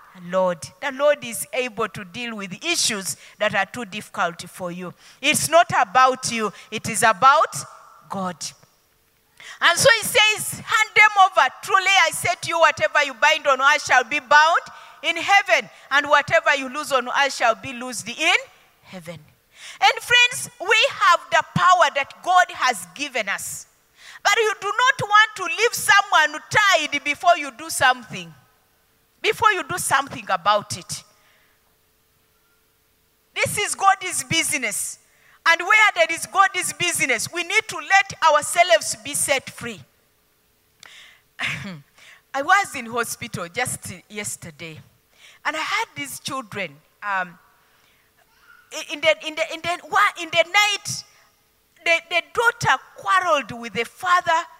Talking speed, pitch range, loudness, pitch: 145 wpm, 220-355 Hz, -19 LUFS, 300 Hz